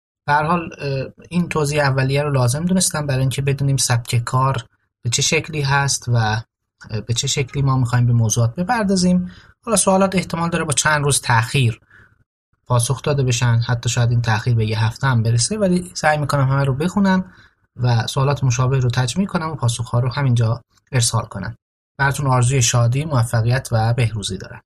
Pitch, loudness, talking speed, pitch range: 130 Hz, -18 LUFS, 175 wpm, 120-145 Hz